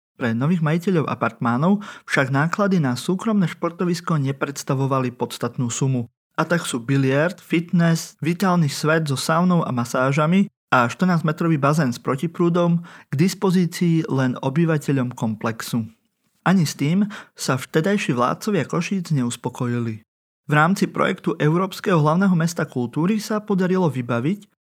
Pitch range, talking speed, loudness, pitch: 135-180 Hz, 125 wpm, -21 LUFS, 160 Hz